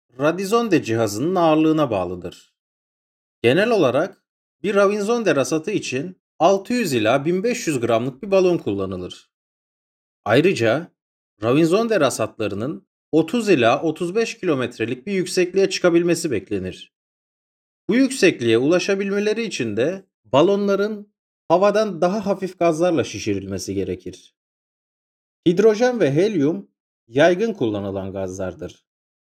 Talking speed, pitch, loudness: 95 wpm, 170 Hz, -20 LUFS